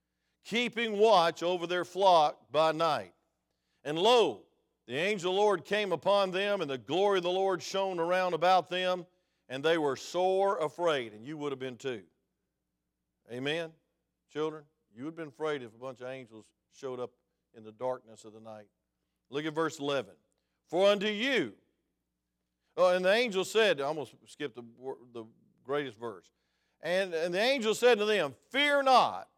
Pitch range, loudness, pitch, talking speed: 125-190 Hz, -30 LUFS, 160 Hz, 180 wpm